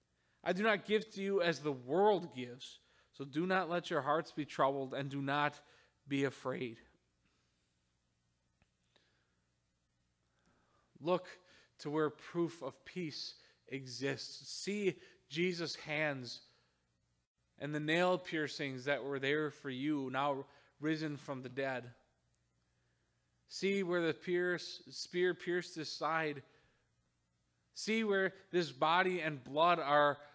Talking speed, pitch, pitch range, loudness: 125 wpm, 145 Hz, 120-170 Hz, -37 LUFS